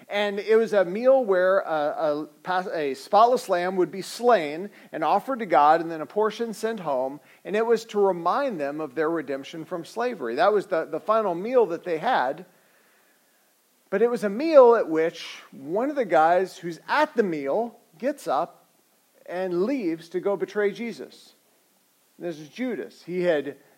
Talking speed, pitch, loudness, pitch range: 180 wpm, 195 Hz, -24 LUFS, 165-230 Hz